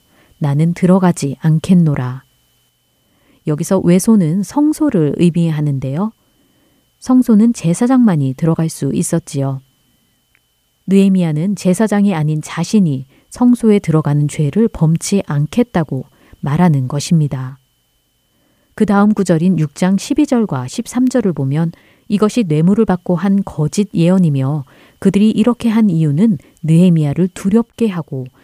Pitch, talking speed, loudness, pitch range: 175 Hz, 265 characters per minute, -14 LUFS, 150-205 Hz